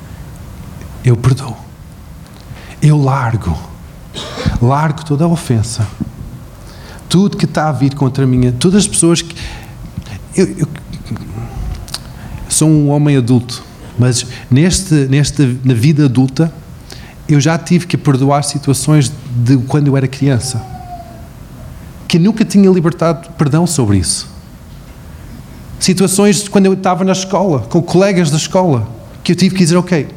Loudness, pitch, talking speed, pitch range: -12 LUFS, 140 Hz, 135 wpm, 125-170 Hz